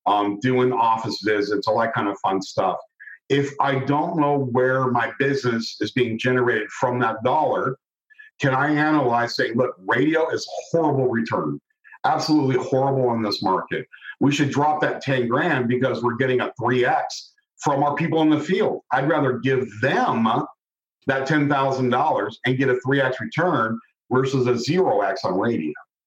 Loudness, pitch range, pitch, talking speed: -21 LUFS, 125-150 Hz, 130 Hz, 165 wpm